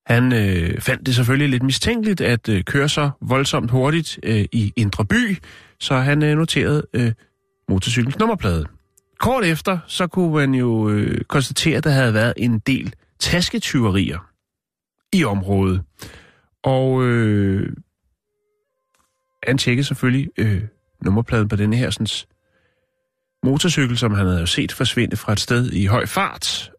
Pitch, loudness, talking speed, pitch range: 125 Hz, -19 LUFS, 145 wpm, 105-145 Hz